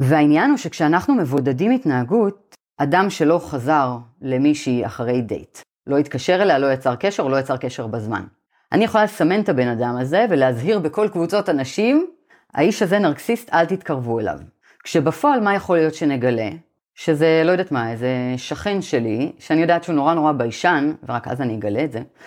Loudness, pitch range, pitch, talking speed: -19 LUFS, 125-190 Hz, 150 Hz, 165 wpm